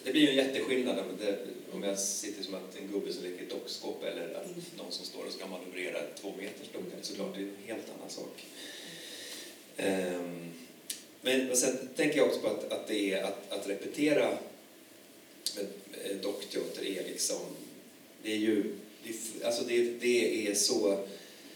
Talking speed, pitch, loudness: 160 wpm, 115 Hz, -34 LUFS